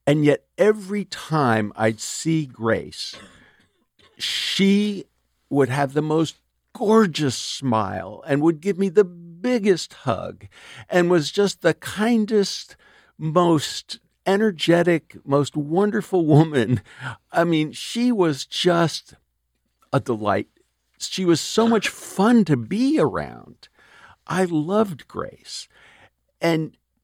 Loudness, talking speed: -21 LUFS, 110 wpm